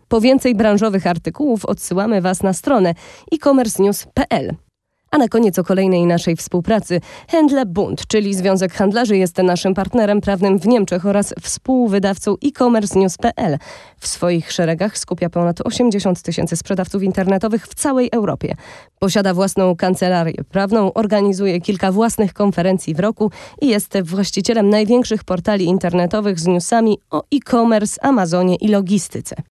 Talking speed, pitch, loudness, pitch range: 130 wpm, 200 Hz, -16 LUFS, 185-225 Hz